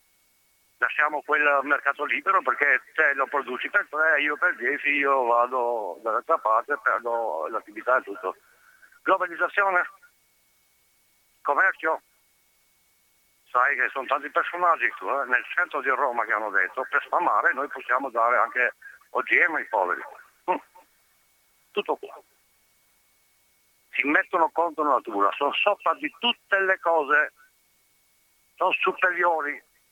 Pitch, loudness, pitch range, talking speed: 150 Hz, -24 LUFS, 140-190 Hz, 125 wpm